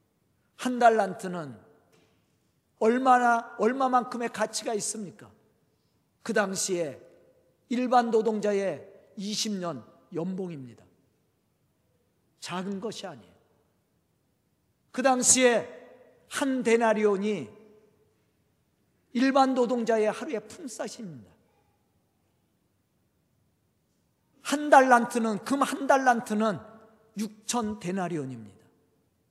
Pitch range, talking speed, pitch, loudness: 180-240 Hz, 180 characters per minute, 215 Hz, -26 LUFS